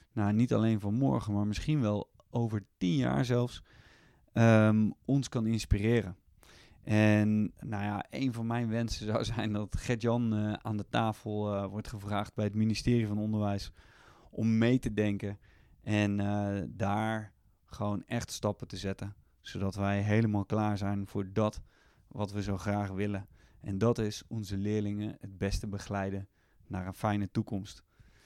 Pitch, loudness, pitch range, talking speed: 105 Hz, -32 LUFS, 100-110 Hz, 155 wpm